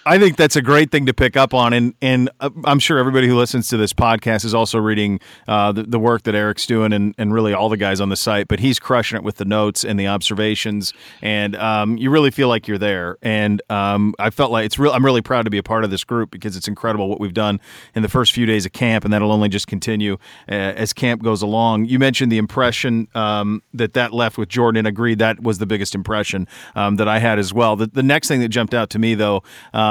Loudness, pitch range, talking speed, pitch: -17 LUFS, 105-120 Hz, 260 wpm, 110 Hz